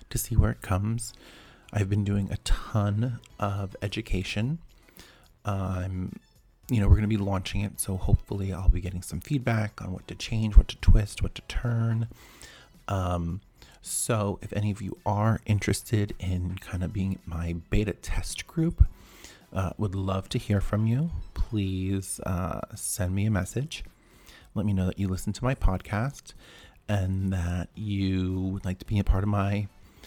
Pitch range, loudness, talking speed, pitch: 95-110 Hz, -29 LUFS, 170 wpm, 100 Hz